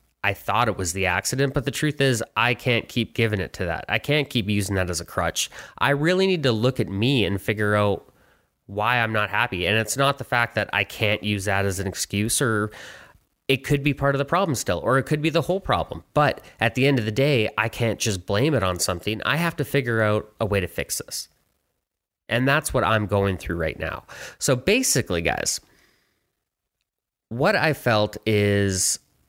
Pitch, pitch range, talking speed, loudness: 110 Hz, 100-135 Hz, 220 wpm, -23 LUFS